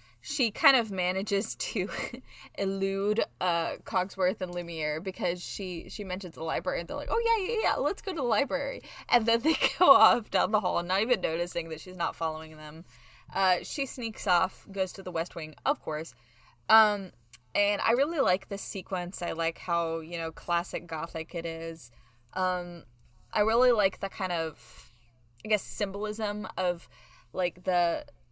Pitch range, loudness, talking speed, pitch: 165-205 Hz, -29 LUFS, 180 wpm, 180 Hz